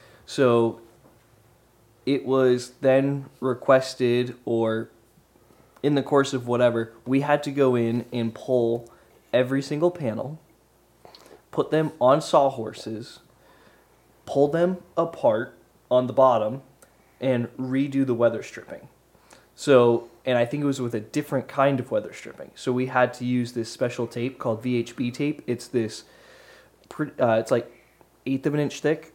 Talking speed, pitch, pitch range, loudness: 145 wpm, 125 Hz, 120-140 Hz, -24 LUFS